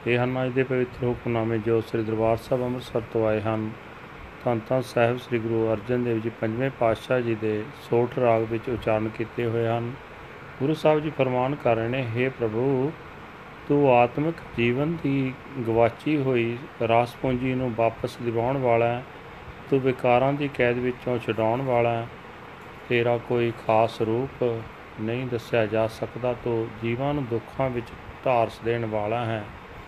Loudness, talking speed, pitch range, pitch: -25 LUFS, 160 wpm, 115-130 Hz, 120 Hz